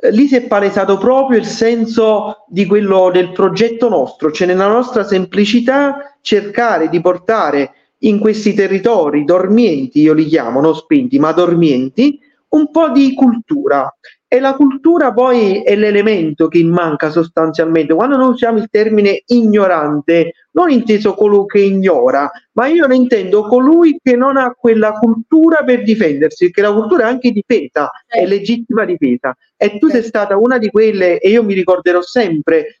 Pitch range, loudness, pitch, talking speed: 180-250 Hz, -12 LUFS, 215 Hz, 160 wpm